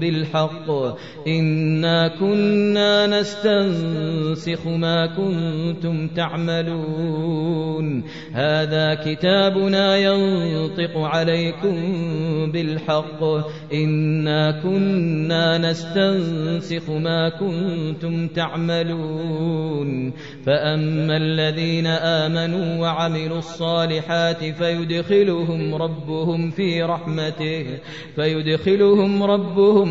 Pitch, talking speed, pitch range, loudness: 165 Hz, 60 wpm, 155-170 Hz, -20 LUFS